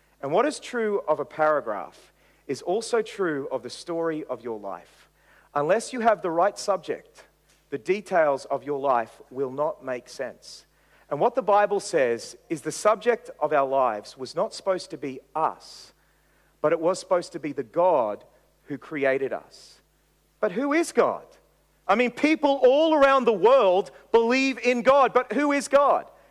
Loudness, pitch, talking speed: -24 LUFS, 205 Hz, 175 wpm